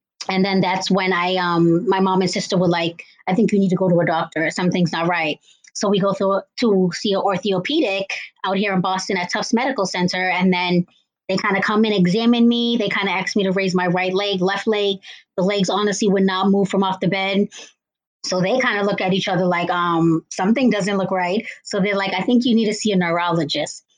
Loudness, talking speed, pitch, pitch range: -19 LUFS, 240 wpm, 195 Hz, 185-205 Hz